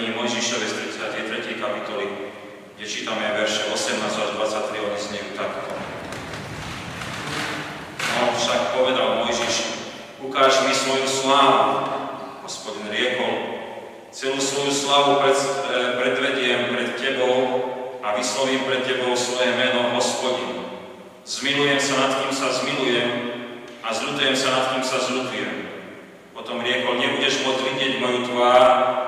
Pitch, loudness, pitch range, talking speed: 125 Hz, -22 LUFS, 120-135 Hz, 120 wpm